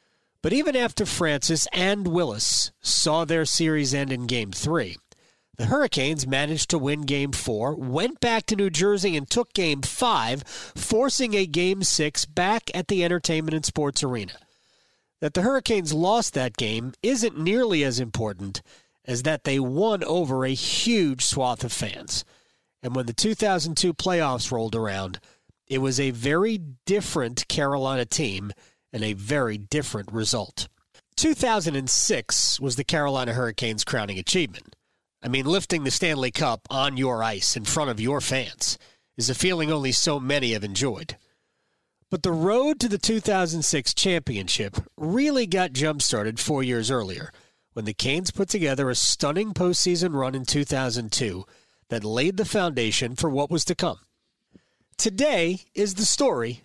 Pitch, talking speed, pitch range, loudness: 145 Hz, 155 wpm, 125-180 Hz, -24 LUFS